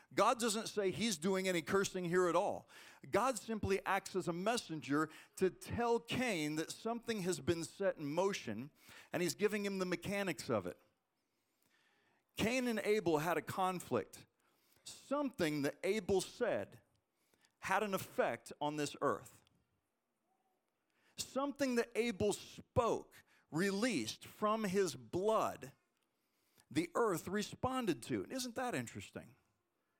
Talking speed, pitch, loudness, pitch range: 130 wpm, 195 Hz, -38 LUFS, 170-230 Hz